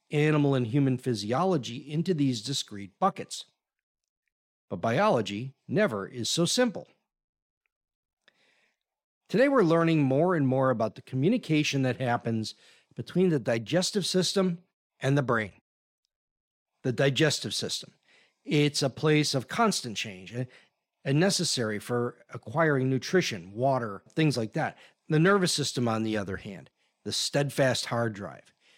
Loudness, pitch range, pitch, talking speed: -27 LUFS, 120-165 Hz, 135 Hz, 125 wpm